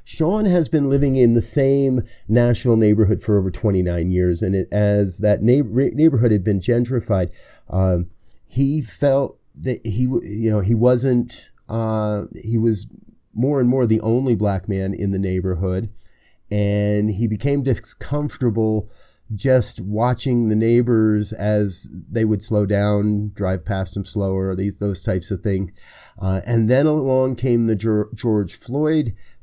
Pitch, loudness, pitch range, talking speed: 110 Hz, -20 LUFS, 100-125 Hz, 150 wpm